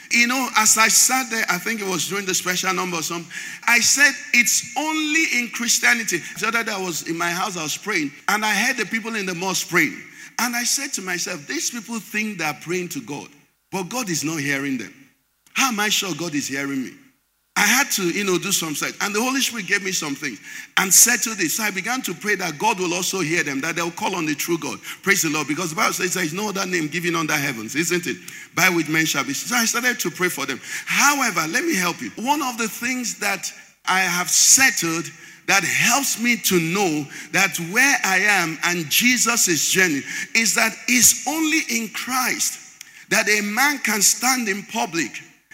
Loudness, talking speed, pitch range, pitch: -19 LUFS, 230 wpm, 170-235 Hz, 195 Hz